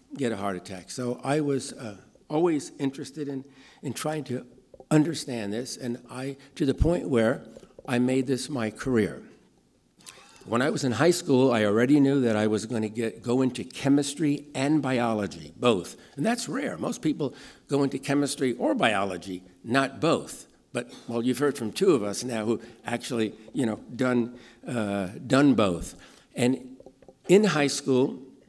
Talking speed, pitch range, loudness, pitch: 170 wpm, 115-140 Hz, -27 LUFS, 130 Hz